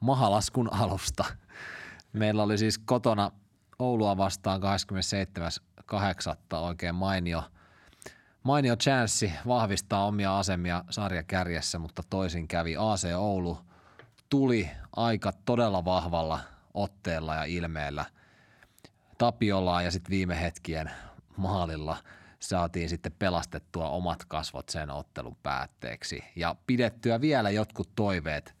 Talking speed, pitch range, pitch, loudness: 100 wpm, 85-105 Hz, 95 Hz, -30 LUFS